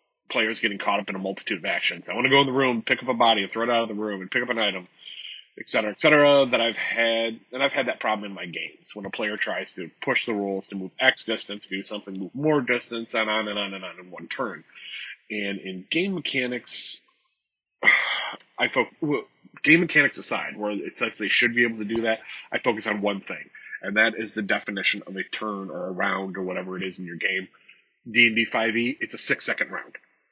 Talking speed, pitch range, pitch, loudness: 245 wpm, 100-120 Hz, 110 Hz, -24 LUFS